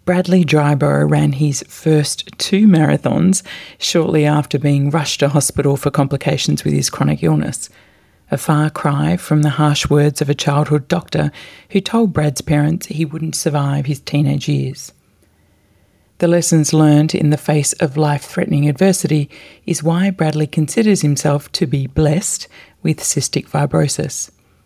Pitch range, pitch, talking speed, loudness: 140-165 Hz, 150 Hz, 150 wpm, -16 LUFS